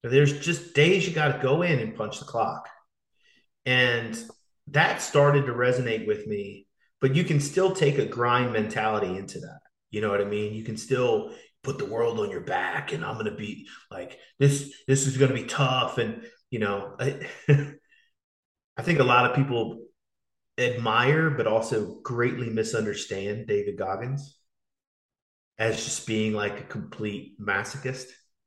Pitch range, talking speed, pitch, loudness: 115-150 Hz, 170 wpm, 130 Hz, -26 LUFS